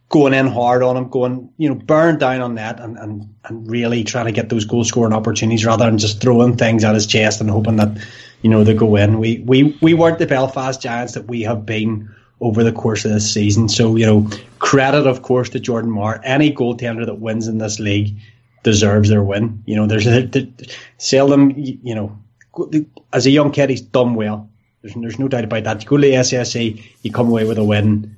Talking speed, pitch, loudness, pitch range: 225 wpm, 115 Hz, -15 LUFS, 110-130 Hz